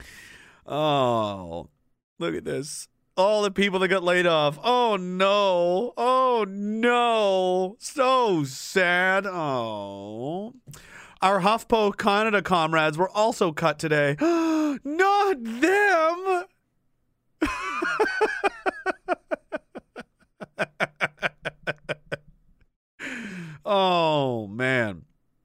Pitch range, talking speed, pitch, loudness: 155-245 Hz, 70 wpm, 190 Hz, -24 LUFS